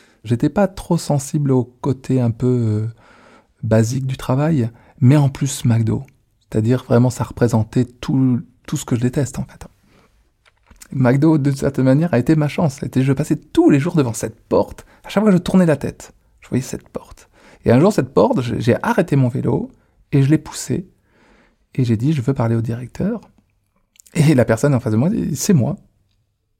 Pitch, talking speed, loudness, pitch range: 130 Hz, 200 wpm, -18 LUFS, 115-150 Hz